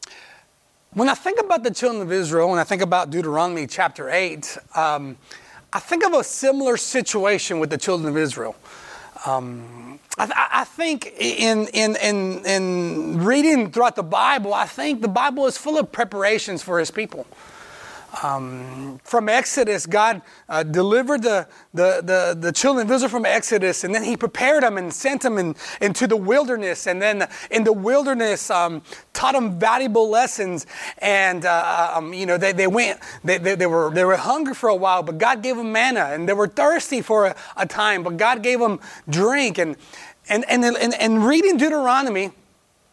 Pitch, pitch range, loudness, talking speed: 210 Hz, 180-245 Hz, -20 LUFS, 185 wpm